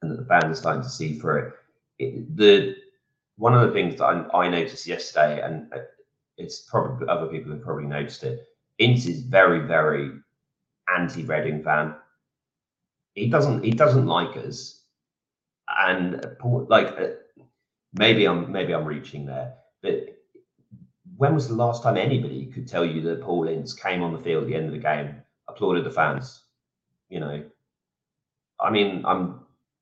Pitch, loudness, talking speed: 115 Hz, -23 LUFS, 165 wpm